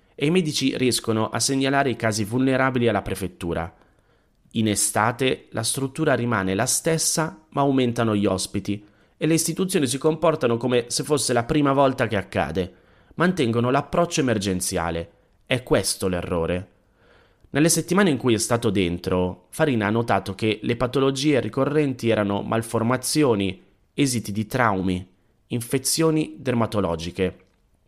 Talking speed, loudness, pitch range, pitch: 135 wpm, -22 LUFS, 100-135 Hz, 115 Hz